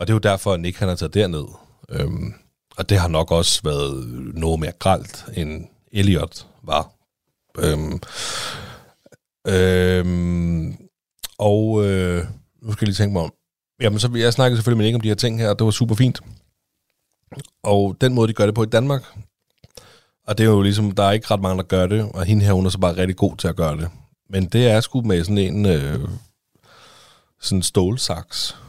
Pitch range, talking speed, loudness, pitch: 90-110 Hz, 195 wpm, -20 LUFS, 100 Hz